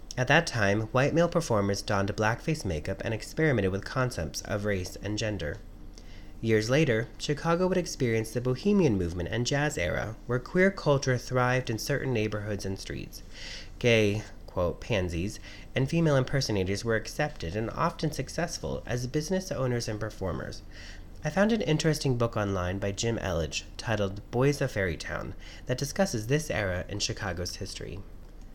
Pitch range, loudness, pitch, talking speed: 95-135 Hz, -29 LUFS, 110 Hz, 155 wpm